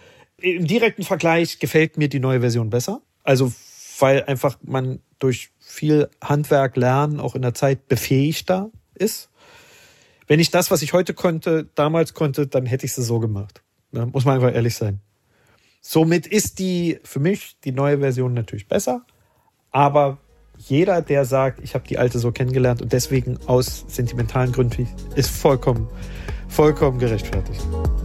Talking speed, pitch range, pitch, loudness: 155 wpm, 120-155 Hz, 135 Hz, -20 LUFS